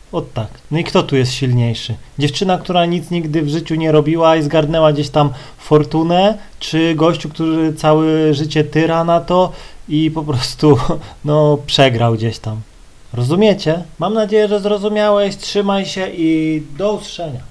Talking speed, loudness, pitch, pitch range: 160 wpm, -15 LUFS, 160 Hz, 150-175 Hz